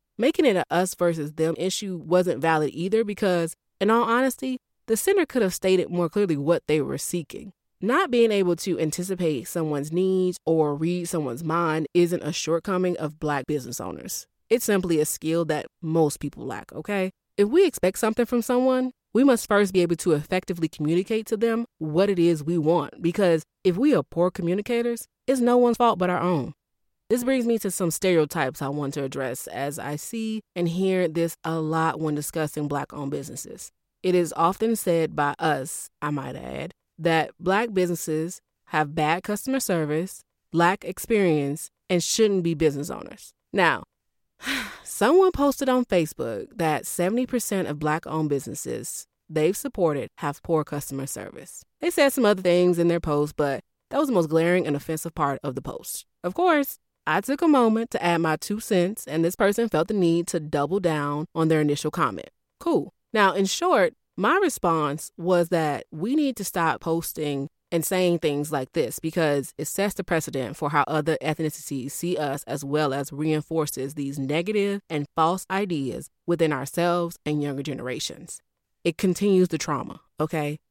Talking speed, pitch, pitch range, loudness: 180 wpm, 170 Hz, 155-195 Hz, -24 LUFS